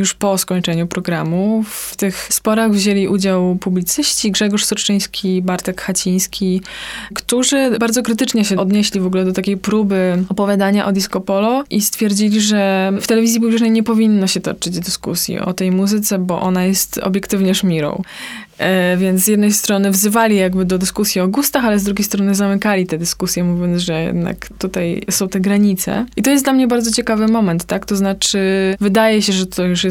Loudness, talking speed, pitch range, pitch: -15 LUFS, 180 wpm, 185-215 Hz, 200 Hz